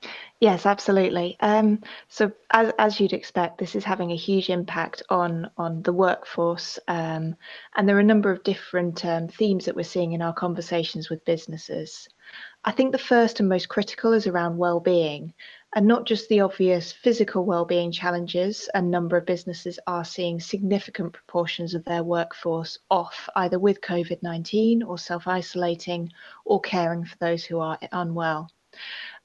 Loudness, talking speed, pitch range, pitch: -24 LUFS, 160 wpm, 170-200 Hz, 180 Hz